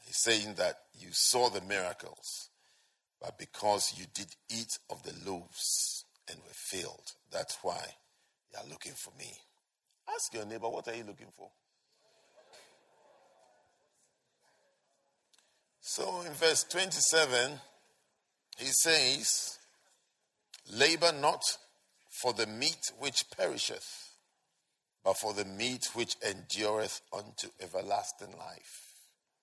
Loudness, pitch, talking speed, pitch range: -32 LUFS, 115 Hz, 110 wpm, 105-145 Hz